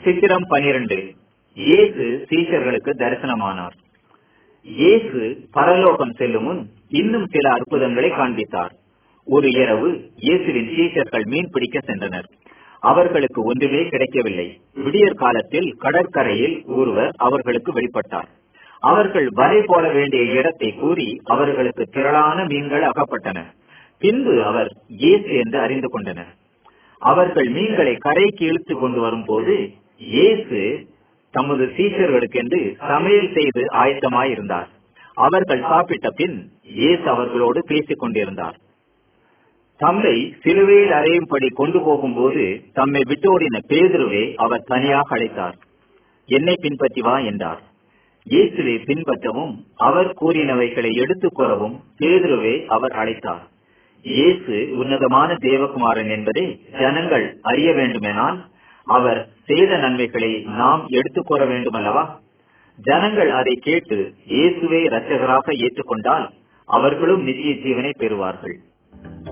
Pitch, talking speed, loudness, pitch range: 145 Hz, 90 wpm, -18 LUFS, 125-185 Hz